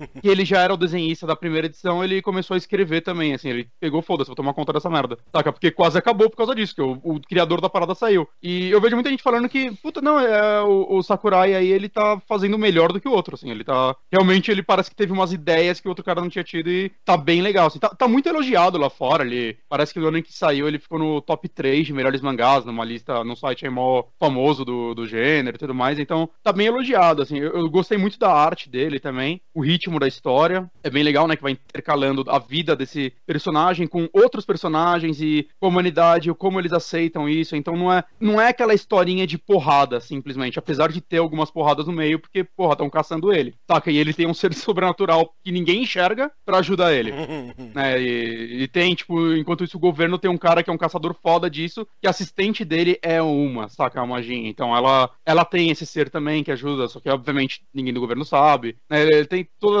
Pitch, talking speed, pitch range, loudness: 165 Hz, 235 wpm, 145-185 Hz, -20 LUFS